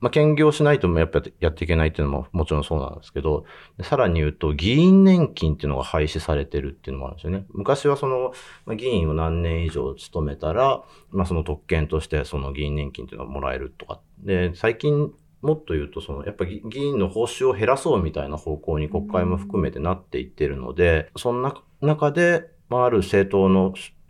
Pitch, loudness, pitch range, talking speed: 90 Hz, -22 LUFS, 75-125 Hz, 430 characters per minute